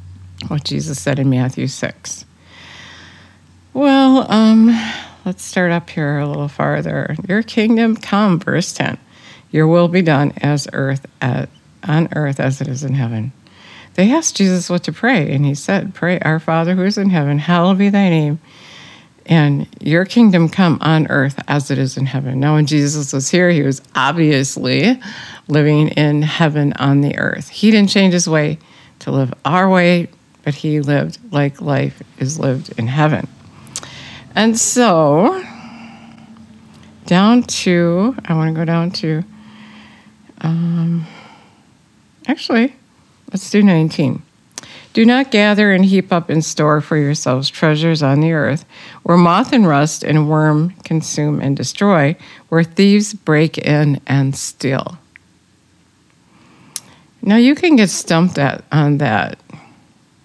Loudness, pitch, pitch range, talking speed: -15 LUFS, 155 Hz, 140-190 Hz, 150 wpm